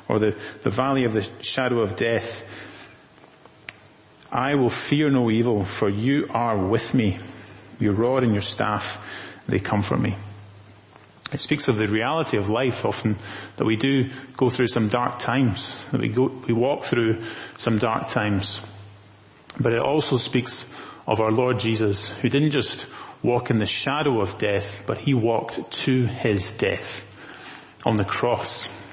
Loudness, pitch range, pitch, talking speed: -23 LUFS, 105-130 Hz, 115 Hz, 165 wpm